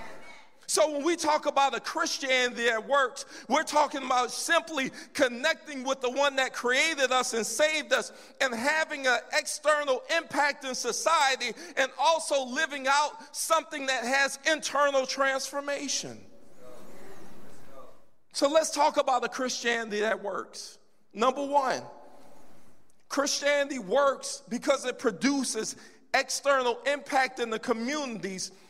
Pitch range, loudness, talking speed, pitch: 255-295 Hz, -27 LUFS, 125 wpm, 275 Hz